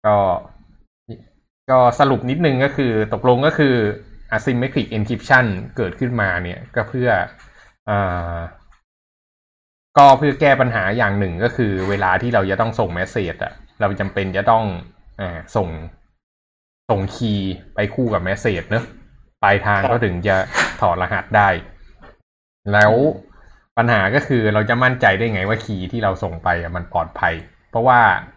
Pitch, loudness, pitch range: 105 Hz, -18 LUFS, 95-120 Hz